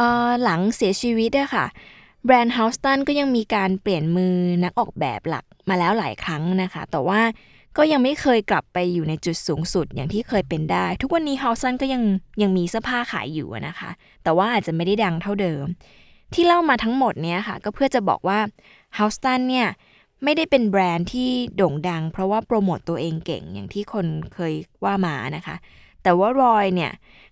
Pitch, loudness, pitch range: 200 Hz, -21 LUFS, 175-240 Hz